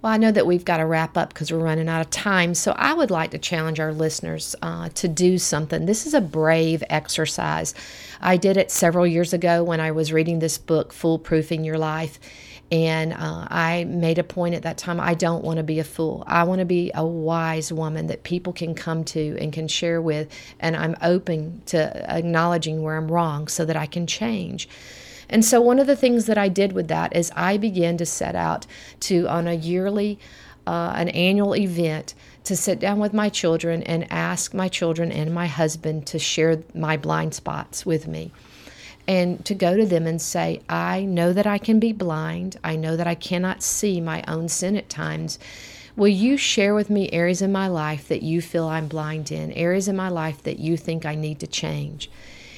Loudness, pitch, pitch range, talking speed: -22 LUFS, 170 Hz, 160-185 Hz, 215 wpm